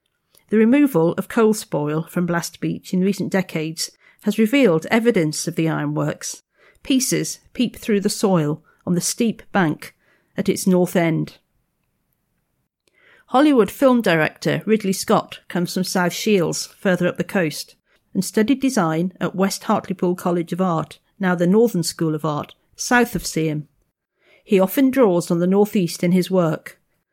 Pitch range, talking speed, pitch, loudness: 170-215 Hz, 155 wpm, 185 Hz, -20 LUFS